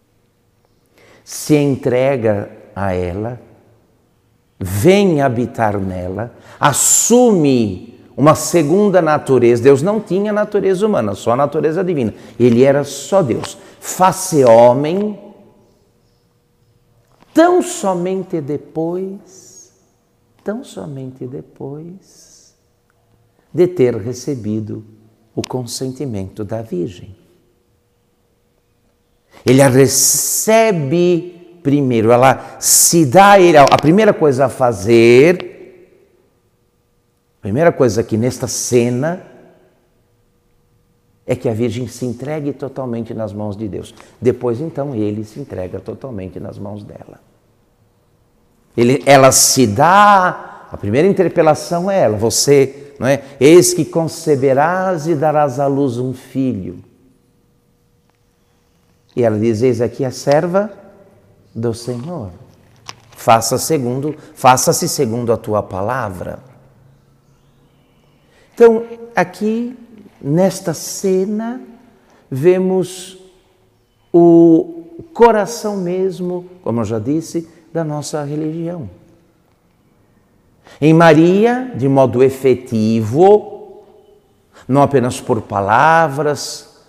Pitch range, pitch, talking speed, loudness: 120-175 Hz, 135 Hz, 95 wpm, -14 LUFS